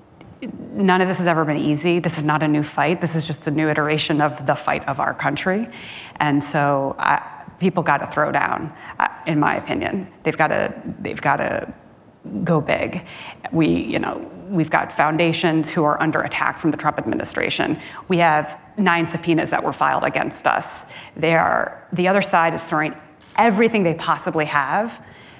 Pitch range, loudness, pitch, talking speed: 150-180 Hz, -20 LUFS, 165 Hz, 180 wpm